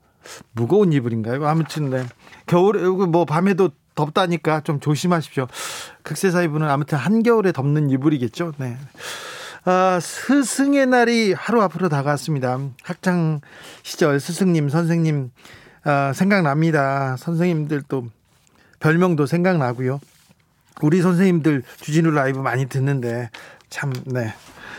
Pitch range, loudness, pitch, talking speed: 140-180 Hz, -20 LUFS, 155 Hz, 280 characters per minute